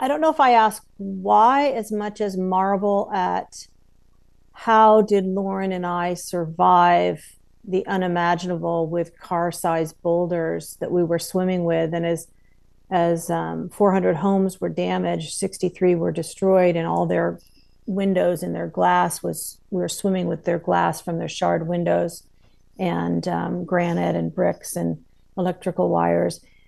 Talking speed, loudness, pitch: 145 wpm, -21 LUFS, 170 Hz